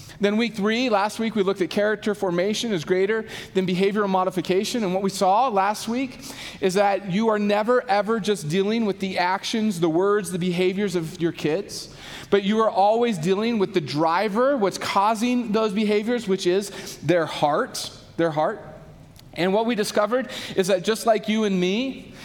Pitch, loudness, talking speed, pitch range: 200 Hz, -23 LUFS, 185 wpm, 185-220 Hz